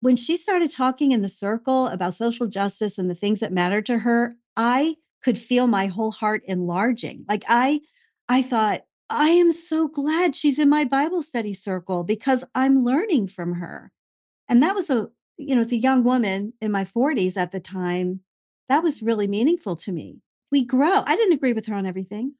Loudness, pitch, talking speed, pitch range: -22 LUFS, 235 Hz, 200 wpm, 200-275 Hz